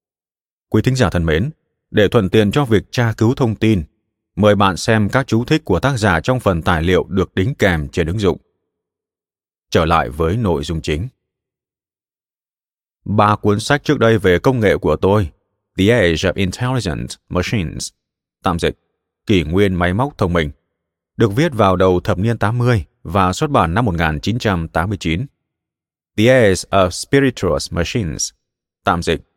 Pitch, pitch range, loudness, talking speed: 100 Hz, 85-115 Hz, -16 LUFS, 165 wpm